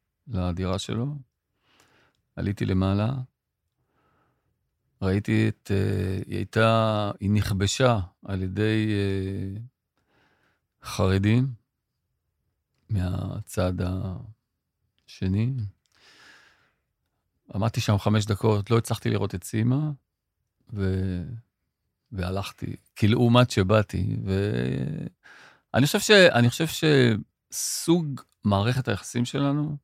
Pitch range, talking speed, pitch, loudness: 95-120 Hz, 70 wpm, 105 Hz, -25 LUFS